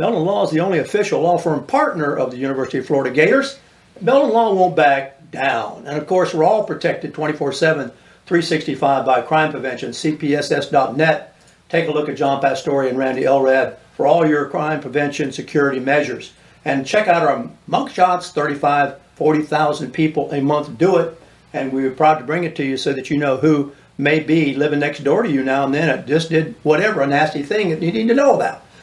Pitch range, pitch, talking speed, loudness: 140-165 Hz, 150 Hz, 200 wpm, -18 LUFS